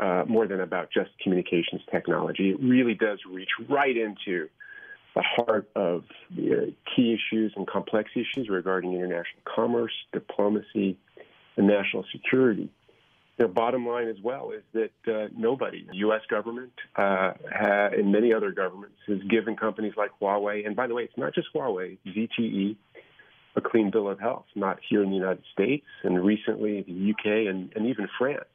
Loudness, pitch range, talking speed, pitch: -27 LUFS, 95-115 Hz, 170 wpm, 105 Hz